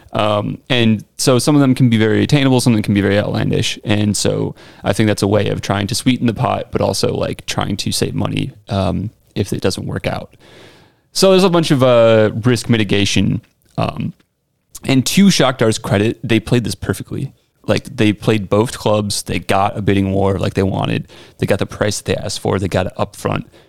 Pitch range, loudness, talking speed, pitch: 100-125 Hz, -16 LUFS, 215 wpm, 110 Hz